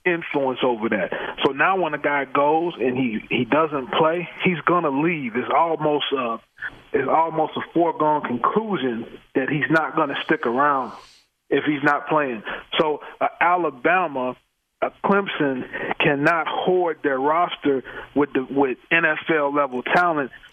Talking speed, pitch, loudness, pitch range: 145 wpm, 150 Hz, -21 LUFS, 135-165 Hz